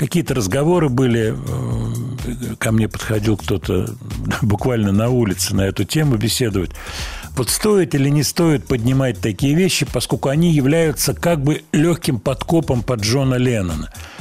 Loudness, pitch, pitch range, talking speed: -18 LUFS, 125 Hz, 110-145 Hz, 135 wpm